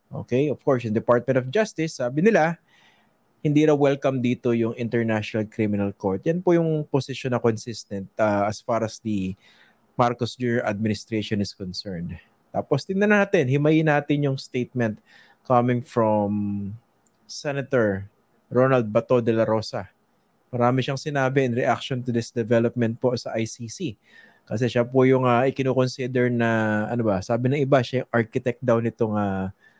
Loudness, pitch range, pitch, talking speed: -23 LUFS, 110-135 Hz, 120 Hz, 155 wpm